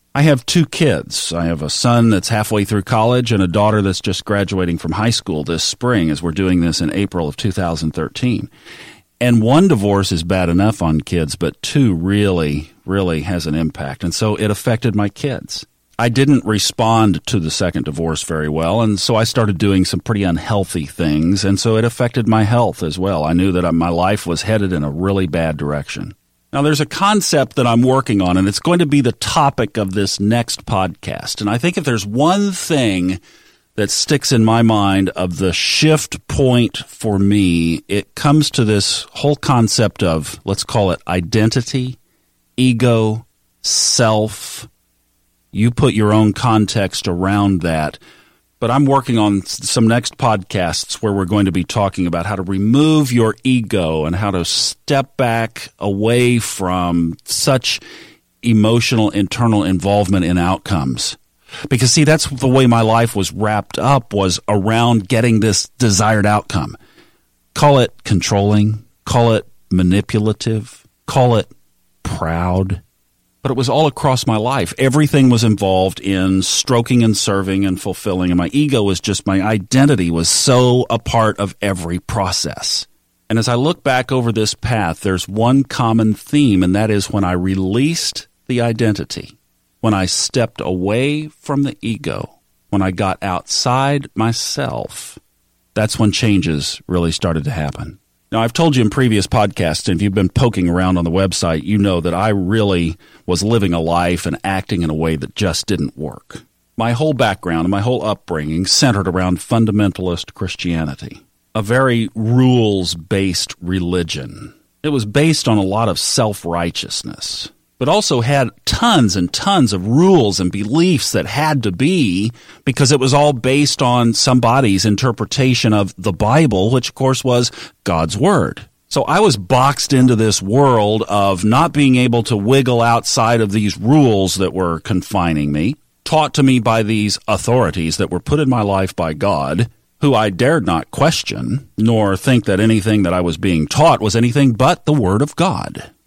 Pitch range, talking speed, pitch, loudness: 95-125 Hz, 170 wpm, 105 Hz, -15 LUFS